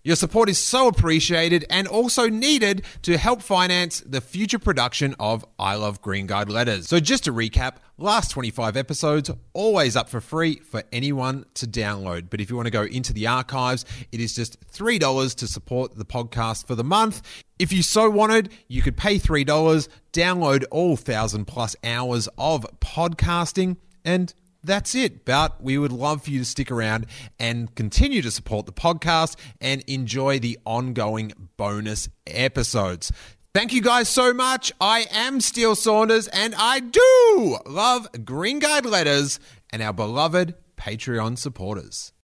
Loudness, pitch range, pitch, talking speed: -22 LUFS, 115-185 Hz, 135 Hz, 165 wpm